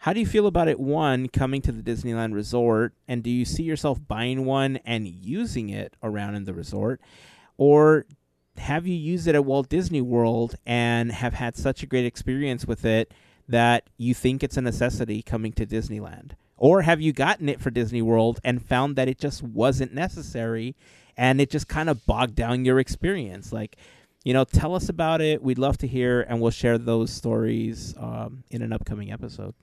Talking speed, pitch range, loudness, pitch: 200 wpm, 115-135 Hz, -24 LUFS, 120 Hz